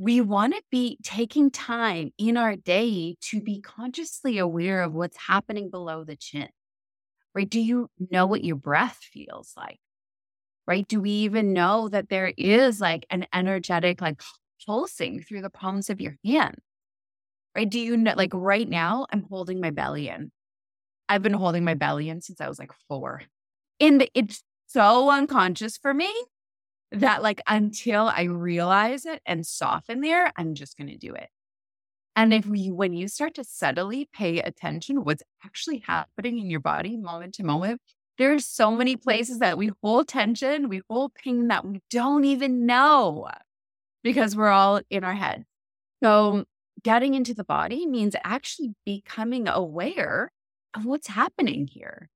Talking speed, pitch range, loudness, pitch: 170 wpm, 175-245 Hz, -24 LUFS, 210 Hz